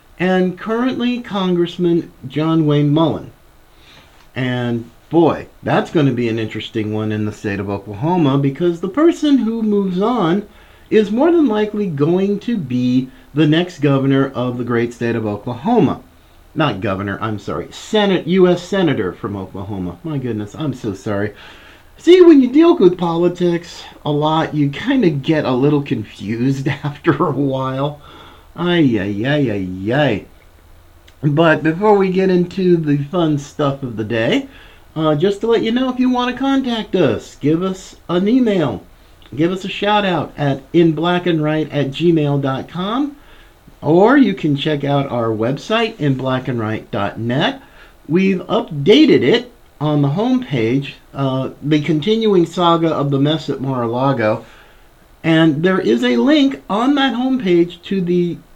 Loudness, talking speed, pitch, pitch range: -16 LUFS, 155 wpm, 155 Hz, 130-190 Hz